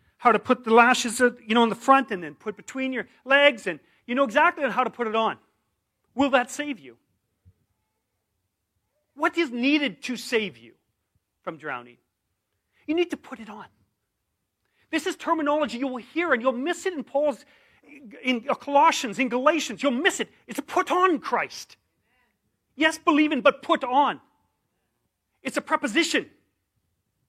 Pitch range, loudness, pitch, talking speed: 220-290 Hz, -24 LUFS, 260 Hz, 165 wpm